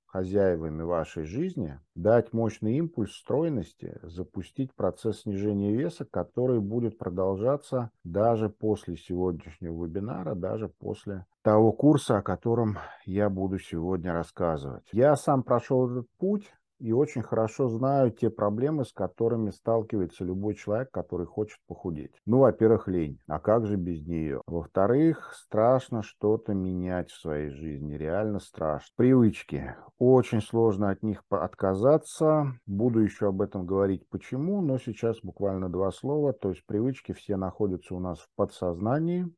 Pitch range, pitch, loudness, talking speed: 90-120 Hz, 105 Hz, -28 LUFS, 135 wpm